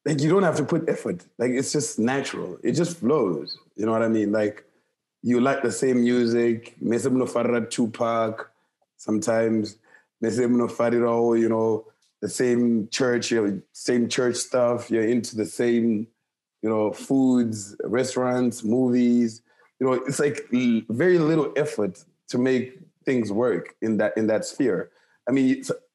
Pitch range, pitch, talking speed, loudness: 115-130 Hz, 120 Hz, 150 wpm, -24 LUFS